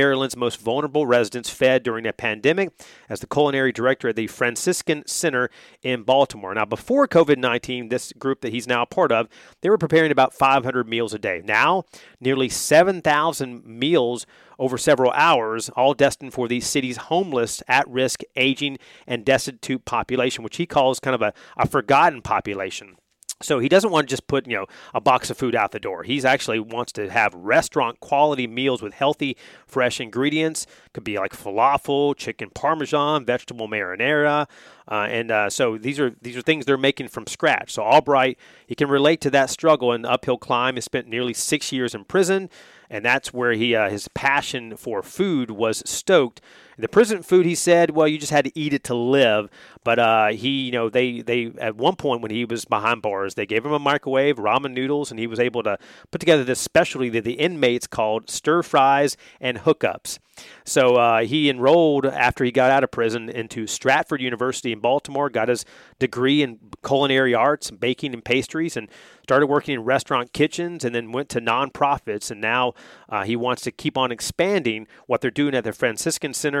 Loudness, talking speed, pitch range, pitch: -21 LUFS, 195 wpm, 120-145 Hz, 130 Hz